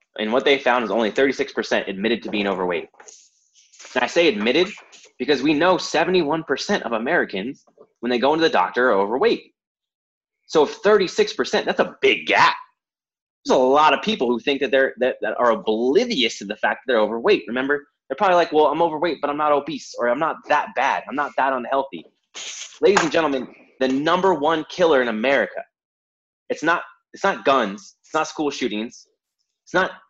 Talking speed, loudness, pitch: 185 wpm, -20 LUFS, 160 Hz